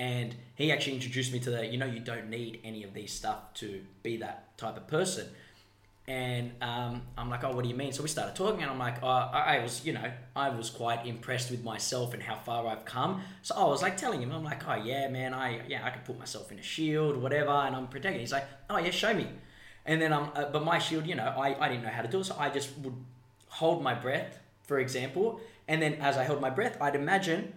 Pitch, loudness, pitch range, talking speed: 130 Hz, -32 LUFS, 120-145 Hz, 260 wpm